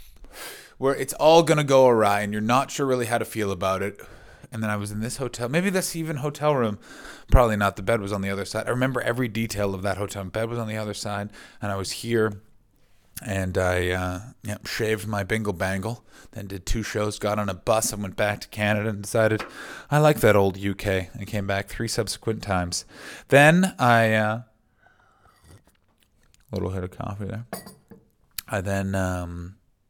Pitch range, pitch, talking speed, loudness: 100-120 Hz, 105 Hz, 205 wpm, -24 LUFS